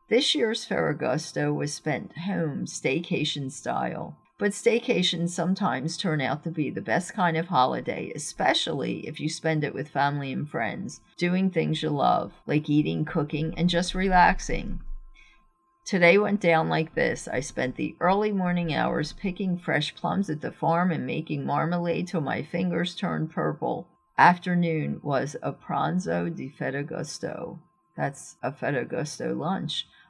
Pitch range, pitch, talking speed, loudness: 155-180 Hz, 165 Hz, 150 wpm, -26 LUFS